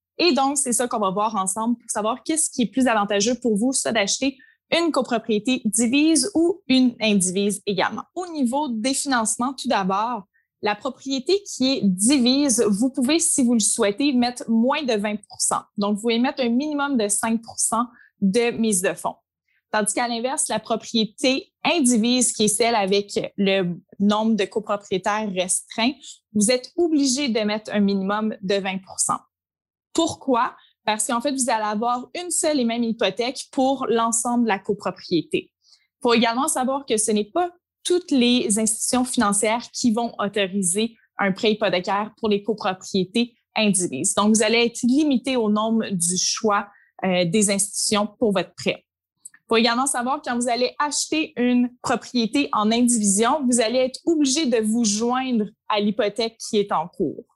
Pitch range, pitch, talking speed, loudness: 210-260 Hz, 235 Hz, 170 wpm, -21 LUFS